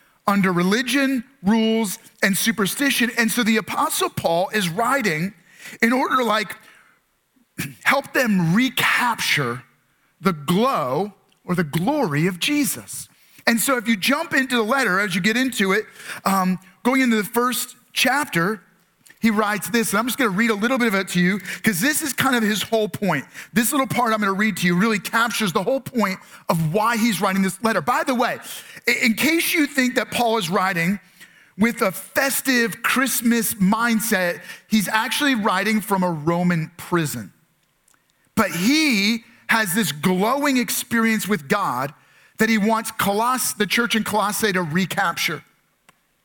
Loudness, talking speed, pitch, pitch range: -20 LUFS, 165 wpm, 220 Hz, 195-245 Hz